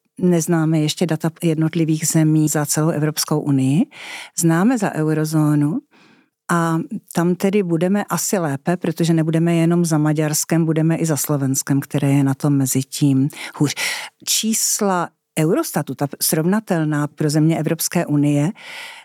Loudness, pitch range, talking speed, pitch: -18 LUFS, 150-175 Hz, 130 wpm, 160 Hz